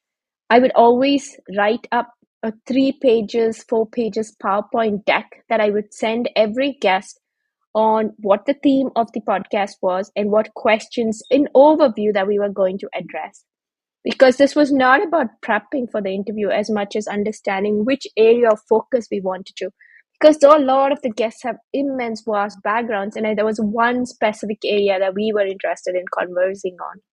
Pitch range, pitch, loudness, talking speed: 205-255 Hz, 220 Hz, -18 LUFS, 180 wpm